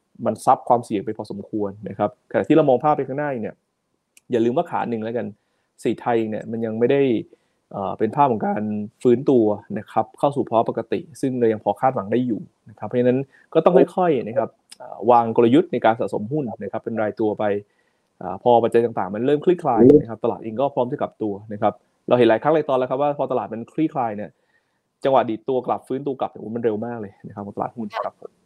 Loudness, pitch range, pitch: -21 LUFS, 110-135 Hz, 120 Hz